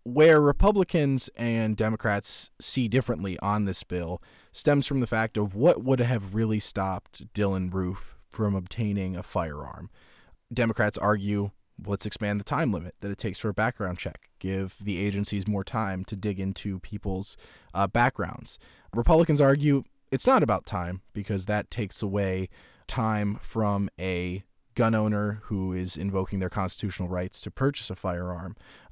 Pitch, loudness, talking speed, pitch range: 105 Hz, -27 LUFS, 155 wpm, 95-115 Hz